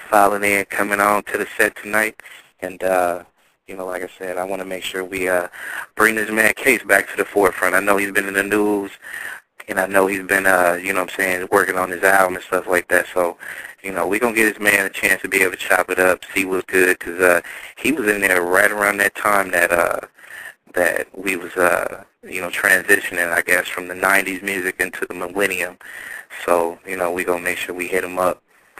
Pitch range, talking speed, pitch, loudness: 90-100 Hz, 245 wpm, 95 Hz, -18 LUFS